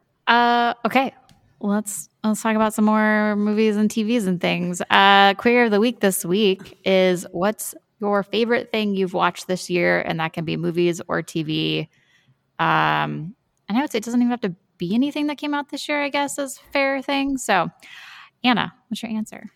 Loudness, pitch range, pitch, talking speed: -21 LUFS, 185-245 Hz, 215 Hz, 195 wpm